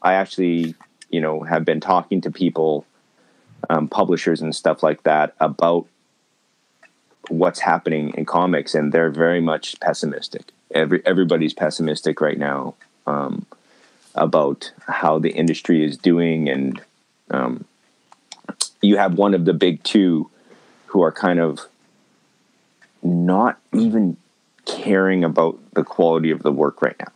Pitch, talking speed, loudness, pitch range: 85 Hz, 135 wpm, -19 LUFS, 80-90 Hz